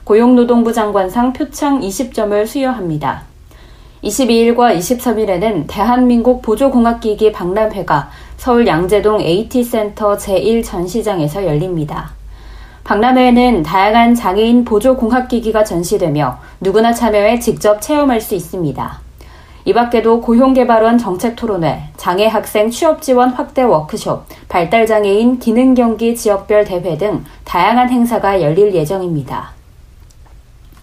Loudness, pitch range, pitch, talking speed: -13 LUFS, 185-240 Hz, 215 Hz, 290 characters per minute